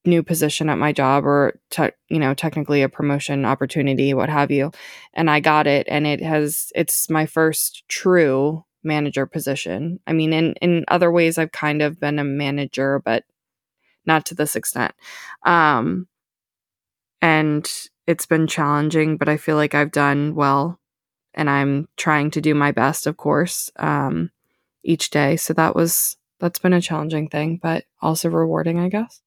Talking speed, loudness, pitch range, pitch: 165 wpm, -19 LUFS, 140-160 Hz, 150 Hz